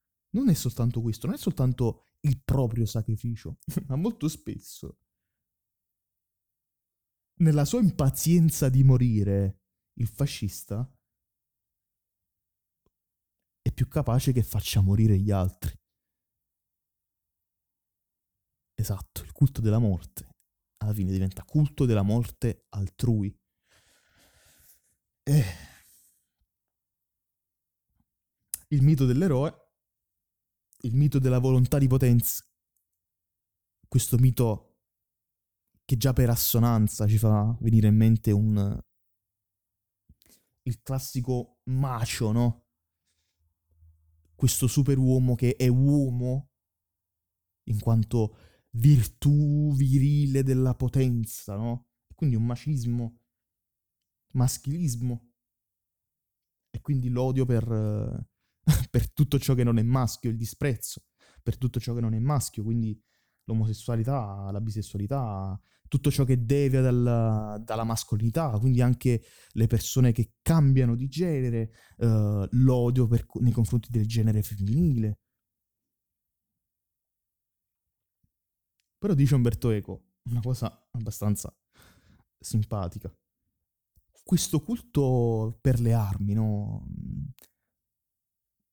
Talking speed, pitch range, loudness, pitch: 95 wpm, 100-130 Hz, -26 LUFS, 115 Hz